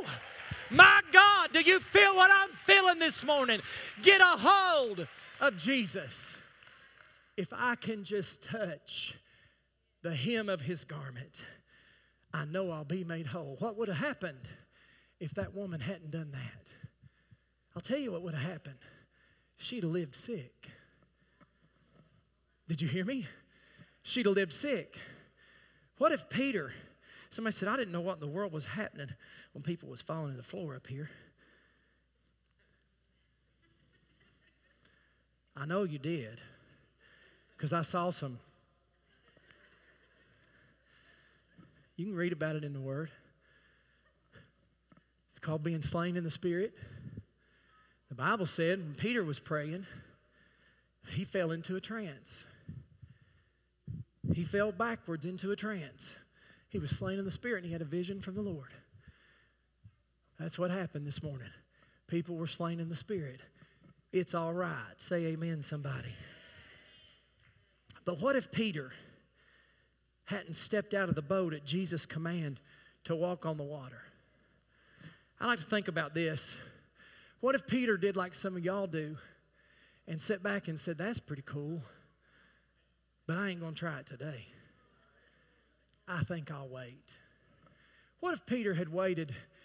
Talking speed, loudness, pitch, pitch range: 145 wpm, -32 LUFS, 170 Hz, 140-195 Hz